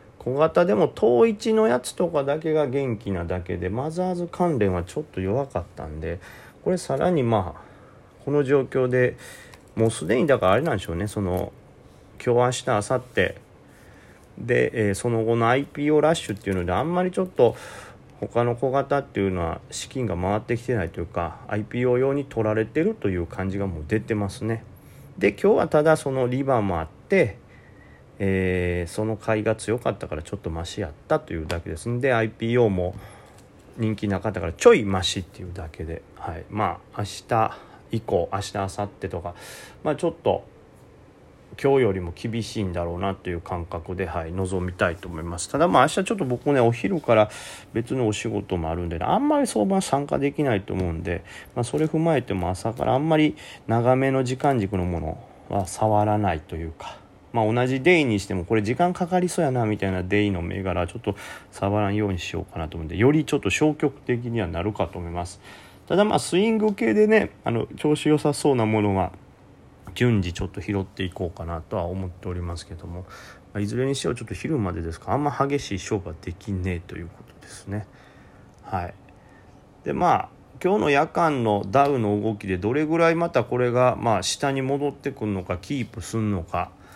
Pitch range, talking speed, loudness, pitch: 95-130 Hz, 380 characters per minute, -24 LUFS, 105 Hz